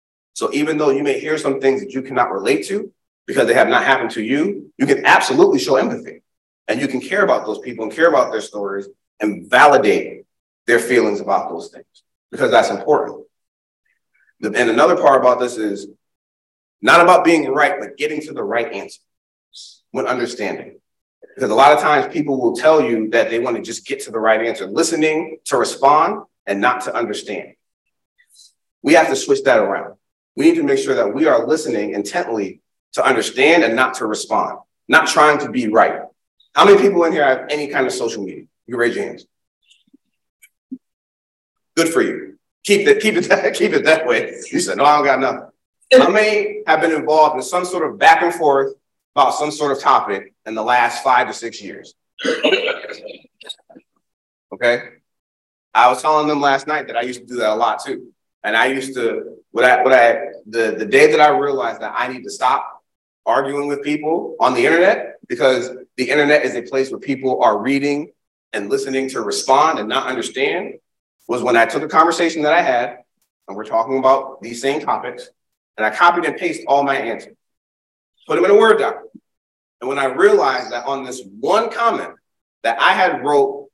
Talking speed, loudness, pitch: 200 wpm, -16 LUFS, 150 Hz